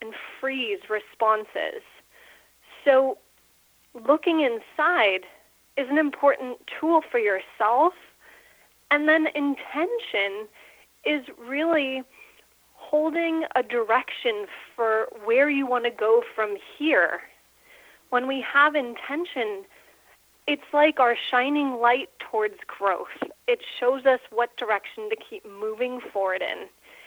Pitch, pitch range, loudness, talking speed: 275 Hz, 240-320 Hz, -24 LUFS, 110 wpm